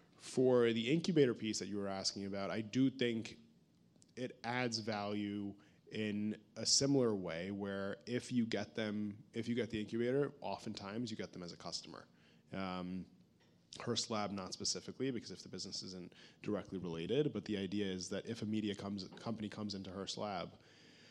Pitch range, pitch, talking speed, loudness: 100-120 Hz, 105 Hz, 180 wpm, -39 LUFS